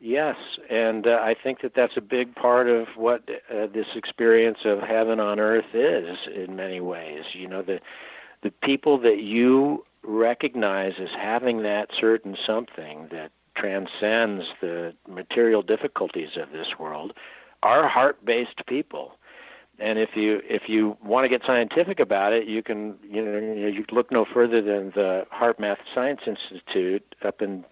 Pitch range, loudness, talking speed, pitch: 105-120 Hz, -24 LUFS, 160 wpm, 110 Hz